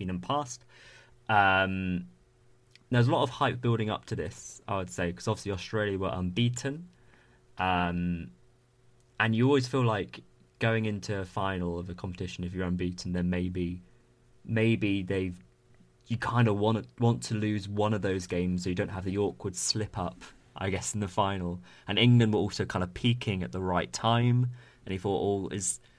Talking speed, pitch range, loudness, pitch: 185 wpm, 90-120 Hz, -30 LUFS, 105 Hz